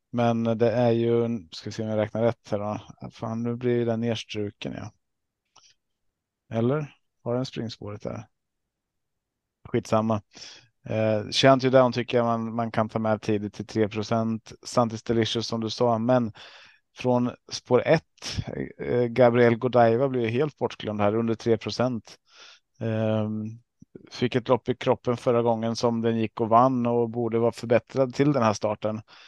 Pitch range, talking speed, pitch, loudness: 110-120 Hz, 155 wpm, 115 Hz, -25 LUFS